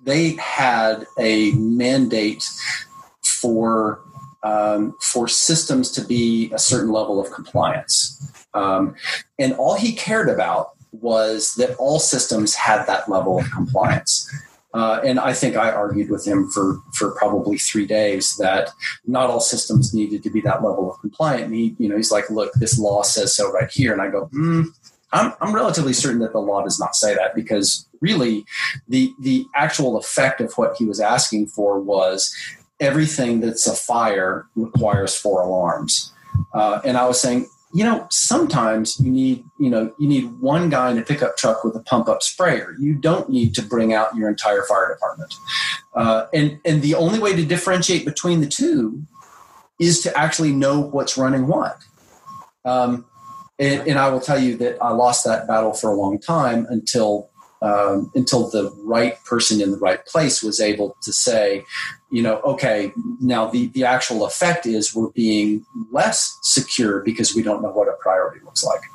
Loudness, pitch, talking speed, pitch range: -19 LUFS, 120 Hz, 180 wpm, 110-150 Hz